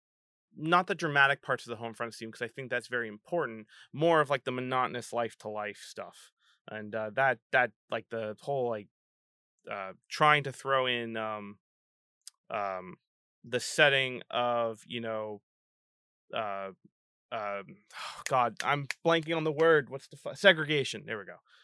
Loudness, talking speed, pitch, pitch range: -30 LUFS, 165 wpm, 120 Hz, 110-140 Hz